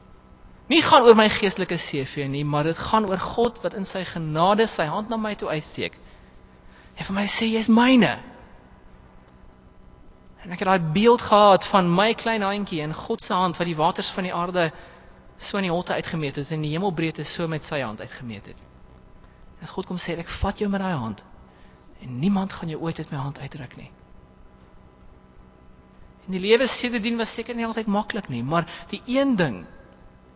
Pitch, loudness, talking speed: 165 Hz, -22 LUFS, 195 wpm